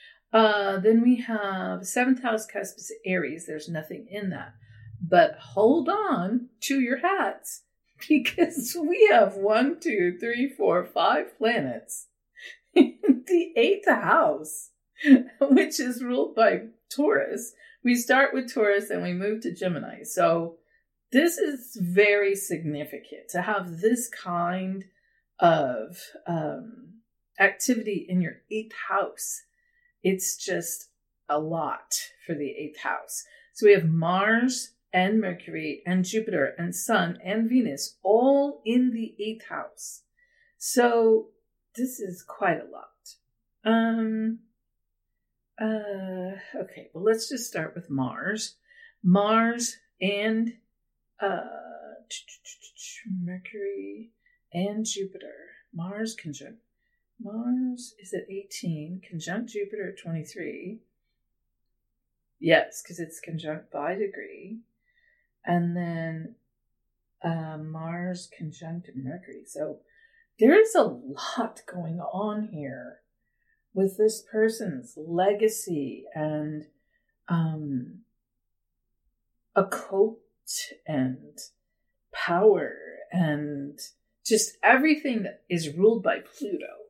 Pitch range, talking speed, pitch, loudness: 180-260 Hz, 105 wpm, 220 Hz, -26 LUFS